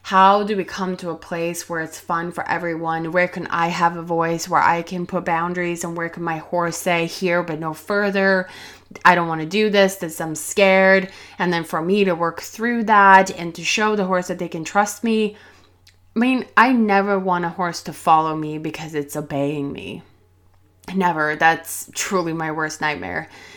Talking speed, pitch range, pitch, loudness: 205 wpm, 160-190 Hz, 170 Hz, -19 LUFS